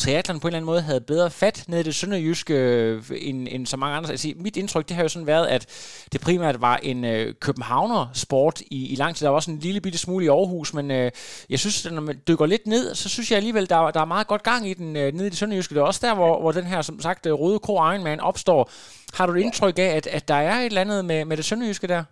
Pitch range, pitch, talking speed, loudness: 145-190 Hz, 165 Hz, 275 wpm, -23 LUFS